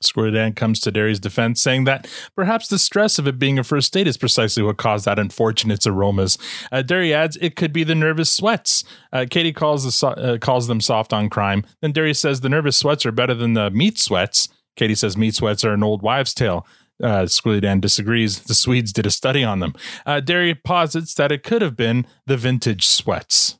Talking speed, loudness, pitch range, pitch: 220 wpm, -18 LUFS, 110-150 Hz, 125 Hz